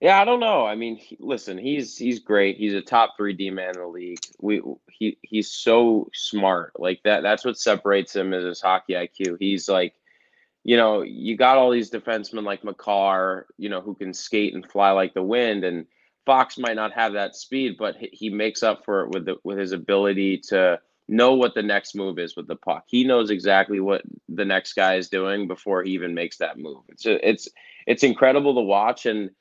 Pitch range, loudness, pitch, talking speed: 95-115 Hz, -22 LUFS, 100 Hz, 220 wpm